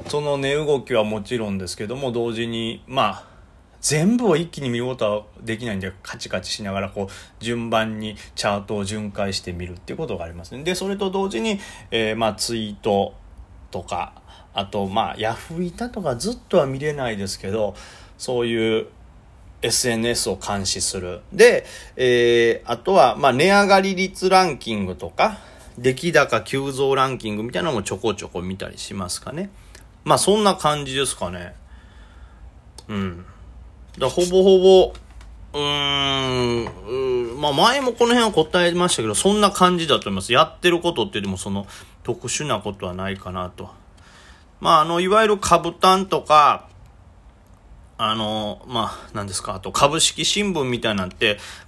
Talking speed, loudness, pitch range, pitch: 320 characters per minute, -20 LUFS, 95-155 Hz, 115 Hz